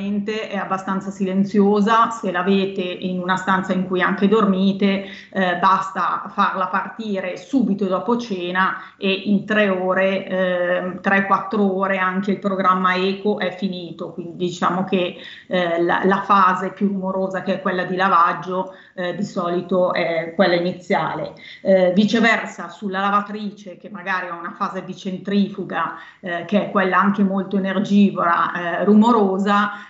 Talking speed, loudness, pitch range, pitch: 150 wpm, -19 LUFS, 185-200 Hz, 190 Hz